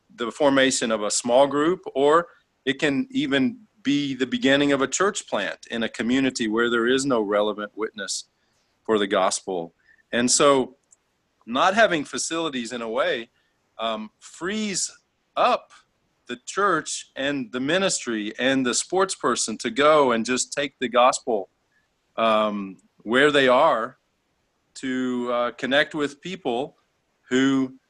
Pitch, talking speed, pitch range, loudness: 130 Hz, 140 wpm, 115-145 Hz, -23 LUFS